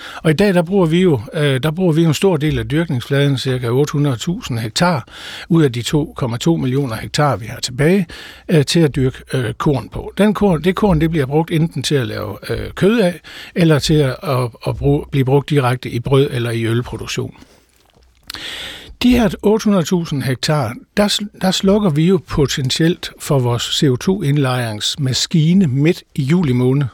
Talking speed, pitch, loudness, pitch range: 165 wpm, 145 Hz, -16 LUFS, 130-175 Hz